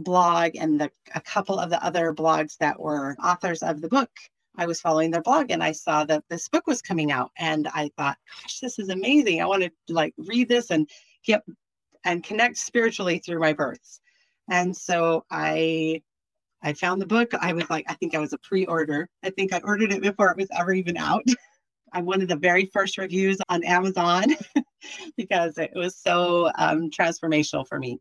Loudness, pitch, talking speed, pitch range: -24 LUFS, 175 Hz, 200 wpm, 160-205 Hz